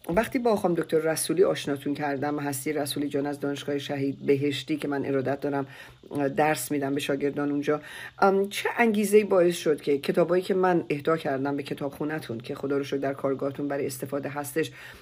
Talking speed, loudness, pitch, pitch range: 185 wpm, -27 LUFS, 145 Hz, 140-160 Hz